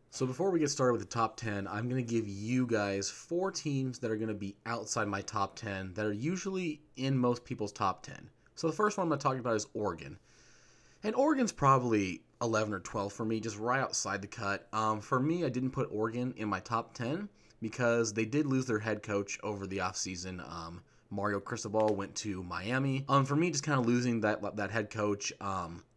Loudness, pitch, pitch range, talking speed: -33 LUFS, 115 Hz, 100-130 Hz, 220 wpm